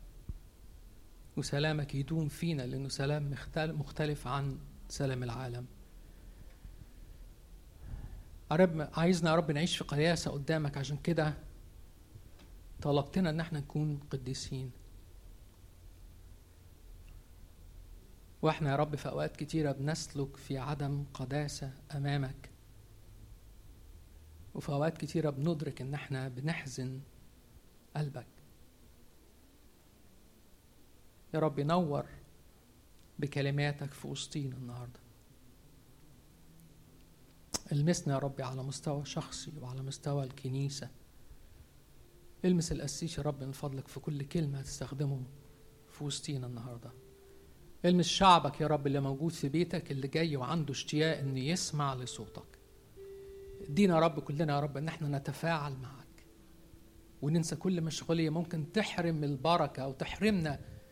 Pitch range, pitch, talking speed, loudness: 115-155 Hz, 140 Hz, 105 wpm, -35 LUFS